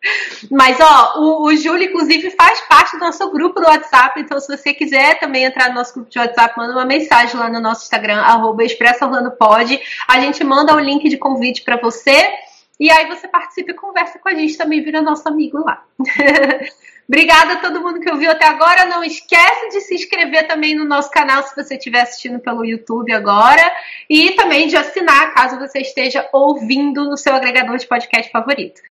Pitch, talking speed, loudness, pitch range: 285 Hz, 195 wpm, -12 LUFS, 255-325 Hz